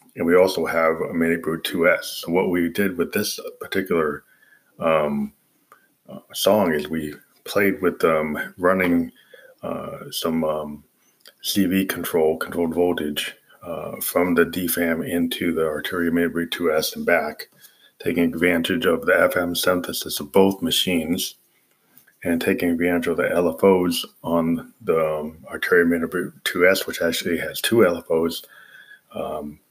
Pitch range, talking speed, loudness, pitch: 80-90 Hz, 135 wpm, -21 LUFS, 85 Hz